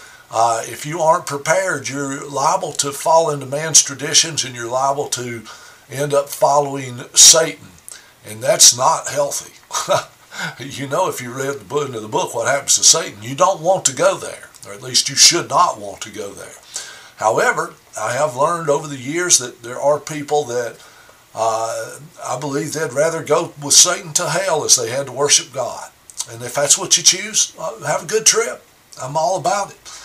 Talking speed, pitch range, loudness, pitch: 195 wpm, 135-160 Hz, -15 LUFS, 145 Hz